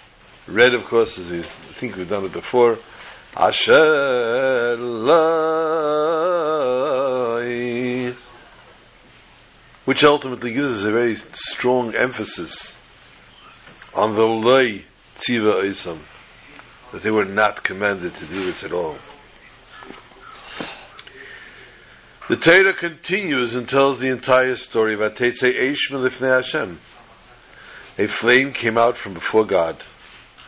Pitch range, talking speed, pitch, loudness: 115-145 Hz, 105 wpm, 125 Hz, -19 LUFS